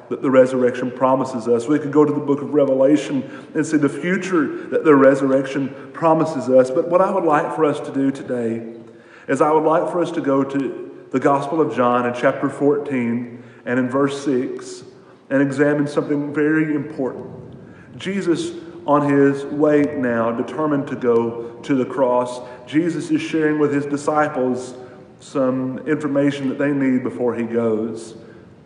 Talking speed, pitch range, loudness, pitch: 170 wpm, 125-150 Hz, -19 LUFS, 140 Hz